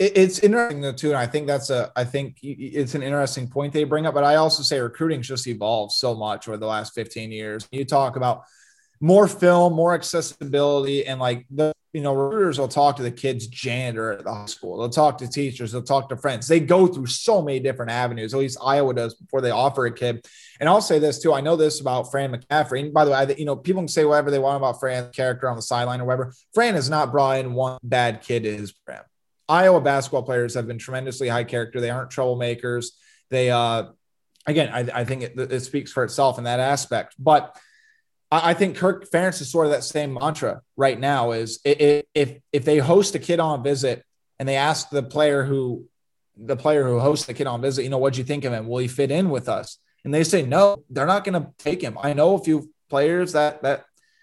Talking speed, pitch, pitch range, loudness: 235 wpm, 140 Hz, 125-150 Hz, -22 LUFS